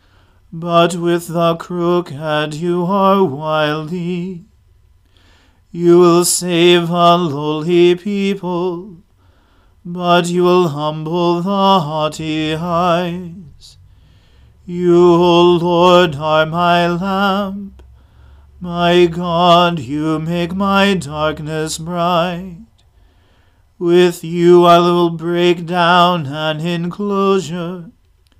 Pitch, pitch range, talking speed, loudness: 175 Hz, 155-175 Hz, 90 wpm, -14 LUFS